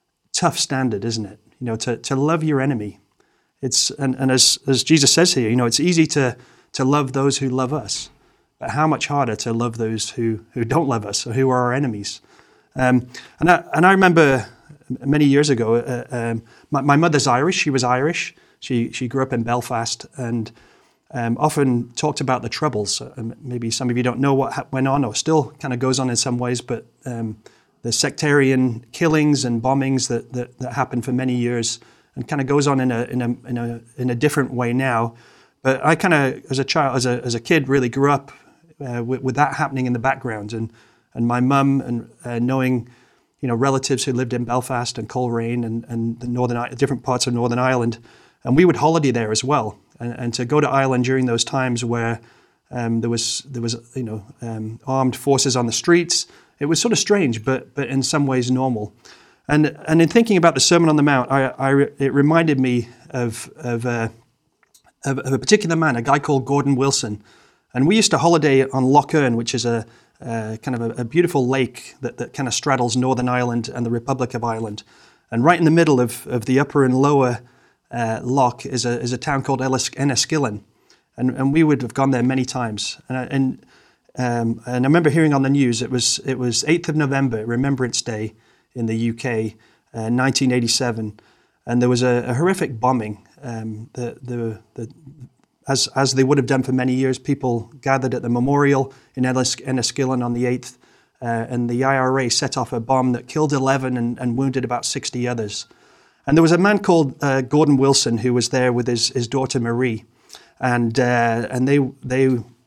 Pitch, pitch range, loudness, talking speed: 130 Hz, 120-140 Hz, -19 LUFS, 210 wpm